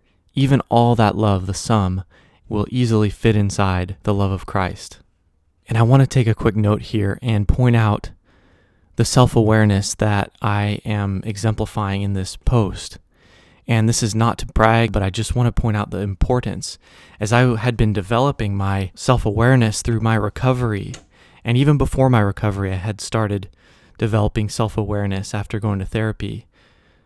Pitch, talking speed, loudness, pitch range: 105 Hz, 170 wpm, -19 LUFS, 100-115 Hz